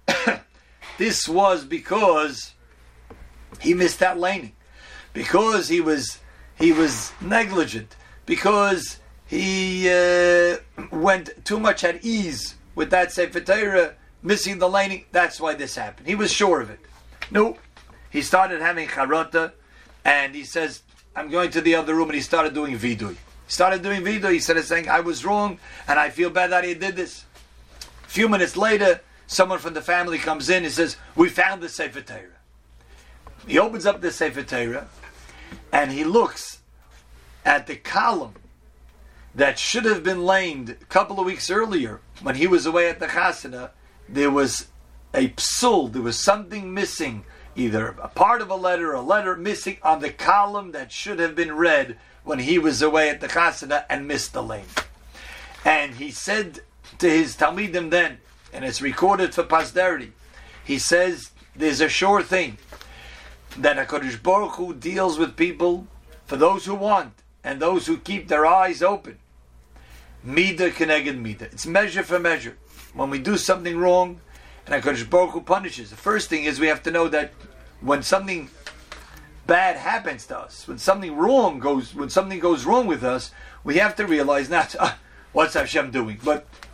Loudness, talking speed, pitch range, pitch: -21 LUFS, 165 wpm, 130-190 Hz, 165 Hz